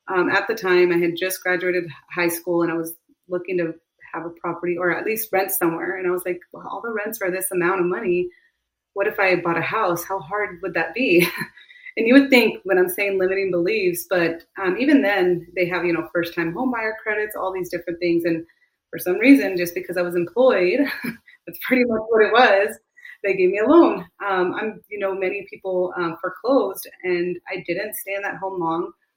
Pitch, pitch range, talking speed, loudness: 185 Hz, 175-215 Hz, 225 wpm, -21 LUFS